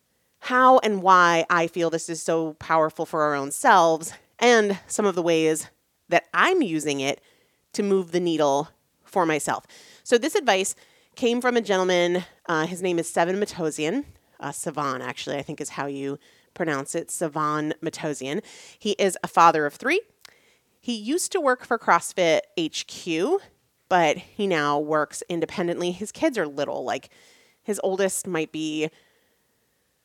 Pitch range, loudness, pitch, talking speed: 155-215 Hz, -23 LUFS, 175 Hz, 160 wpm